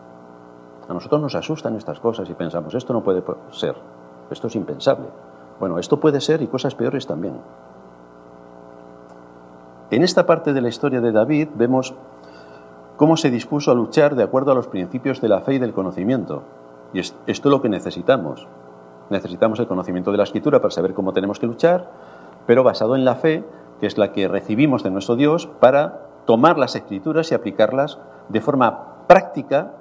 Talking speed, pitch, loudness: 180 wpm, 105 Hz, -19 LUFS